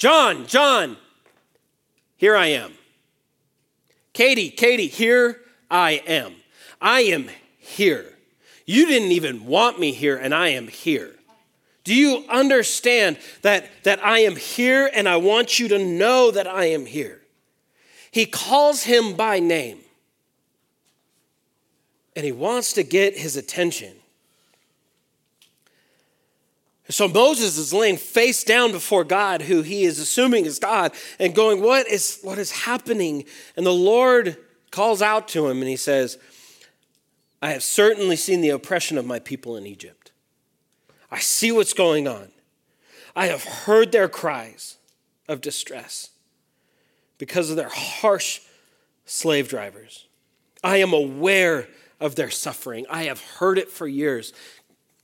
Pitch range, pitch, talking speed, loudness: 165-245 Hz, 205 Hz, 135 wpm, -19 LUFS